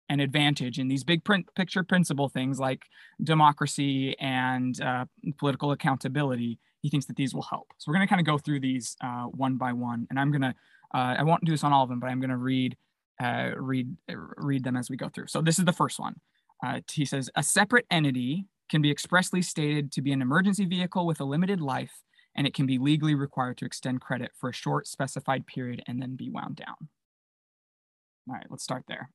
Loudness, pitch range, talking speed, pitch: -28 LUFS, 130-155 Hz, 220 wpm, 140 Hz